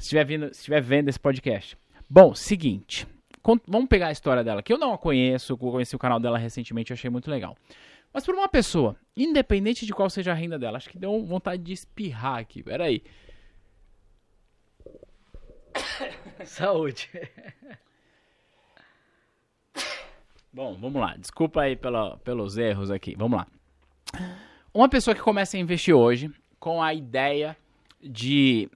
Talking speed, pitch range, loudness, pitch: 150 wpm, 120-190 Hz, -25 LUFS, 145 Hz